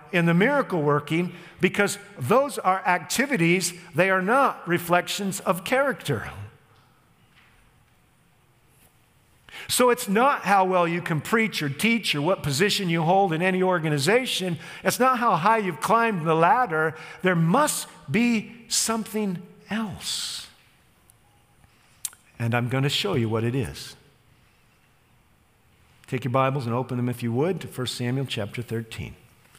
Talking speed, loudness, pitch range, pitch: 140 wpm, -23 LUFS, 135-200 Hz, 175 Hz